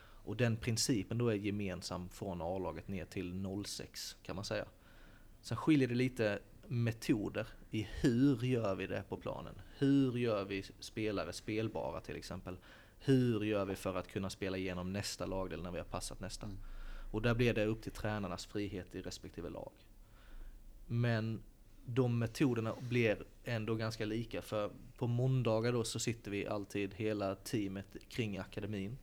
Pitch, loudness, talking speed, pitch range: 105 Hz, -38 LUFS, 160 wpm, 95-115 Hz